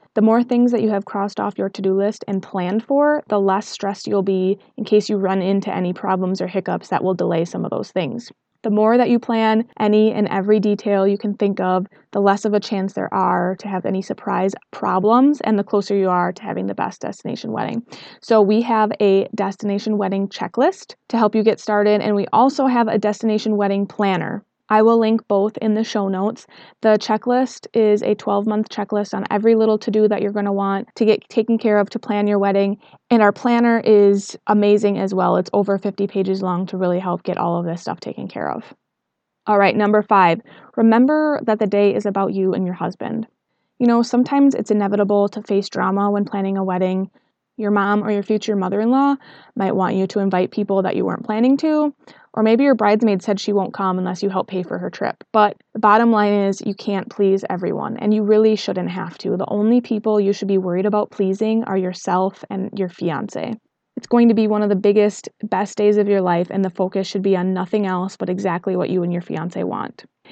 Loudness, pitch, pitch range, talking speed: -19 LUFS, 205 Hz, 195-220 Hz, 225 wpm